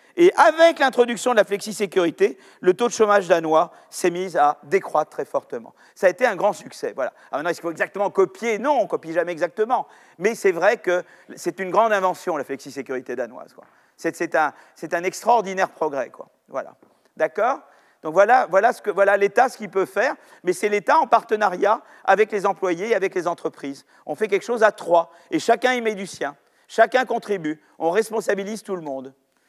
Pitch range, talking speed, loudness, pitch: 175-230 Hz, 205 wpm, -21 LUFS, 200 Hz